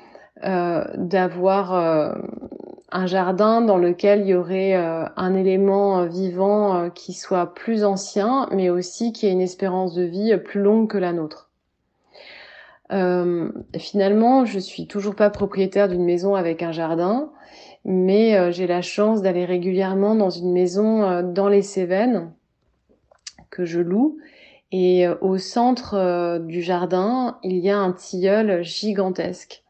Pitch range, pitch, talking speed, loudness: 180-205 Hz, 190 Hz, 150 wpm, -20 LUFS